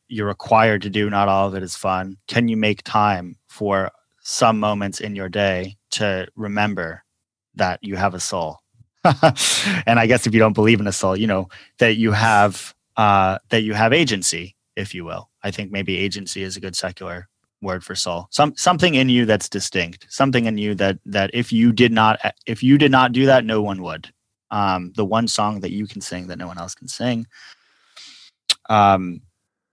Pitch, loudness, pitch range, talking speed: 105 Hz, -19 LUFS, 95-115 Hz, 200 wpm